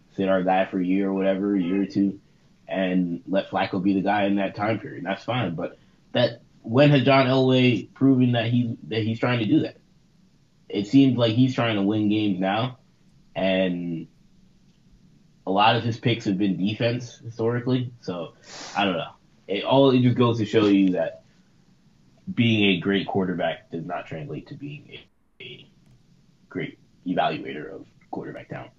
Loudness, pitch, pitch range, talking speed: -23 LUFS, 110 Hz, 95-125 Hz, 185 wpm